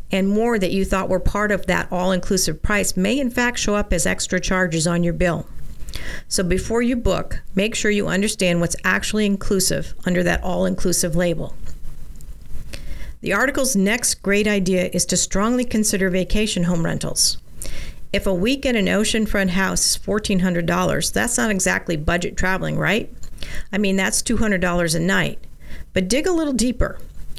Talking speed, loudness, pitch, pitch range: 170 wpm, -20 LUFS, 190 Hz, 175-210 Hz